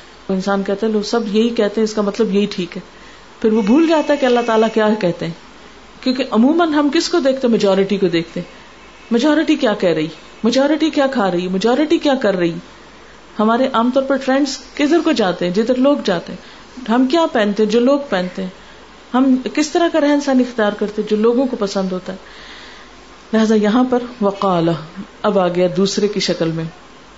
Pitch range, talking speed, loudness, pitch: 195-265 Hz, 210 wpm, -16 LUFS, 220 Hz